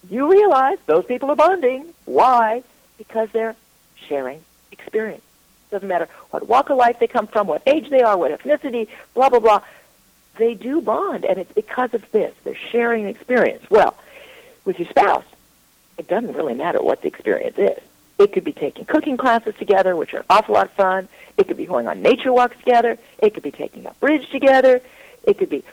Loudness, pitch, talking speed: -18 LUFS, 260 Hz, 200 wpm